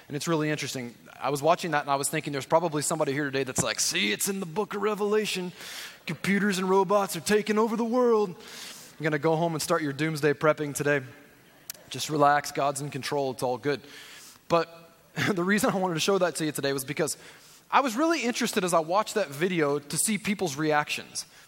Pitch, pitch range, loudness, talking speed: 160 Hz, 145-200 Hz, -27 LUFS, 220 wpm